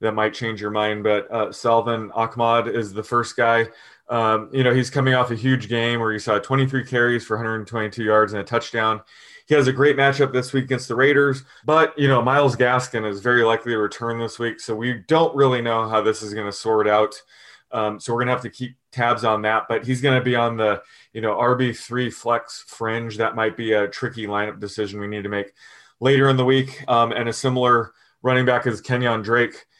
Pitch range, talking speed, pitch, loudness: 110-125 Hz, 230 wpm, 115 Hz, -21 LUFS